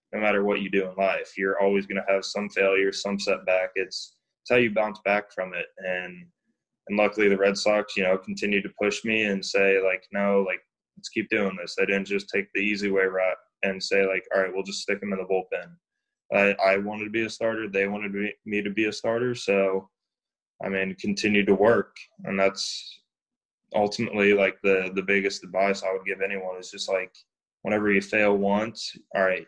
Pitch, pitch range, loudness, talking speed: 100 Hz, 95-105 Hz, -25 LUFS, 225 wpm